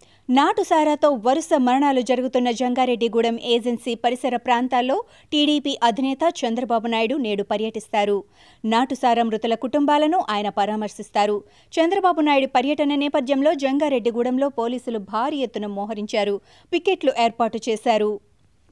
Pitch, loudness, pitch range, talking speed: 245 Hz, -21 LUFS, 225-285 Hz, 100 wpm